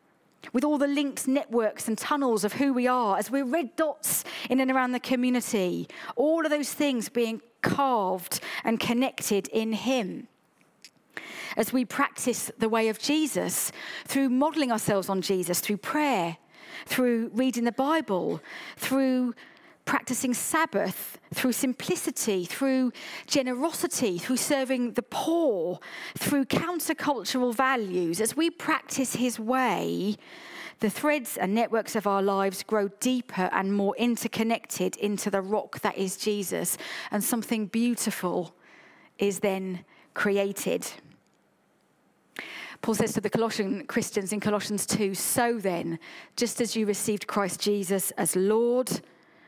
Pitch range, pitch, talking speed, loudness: 205-265 Hz, 235 Hz, 135 wpm, -27 LUFS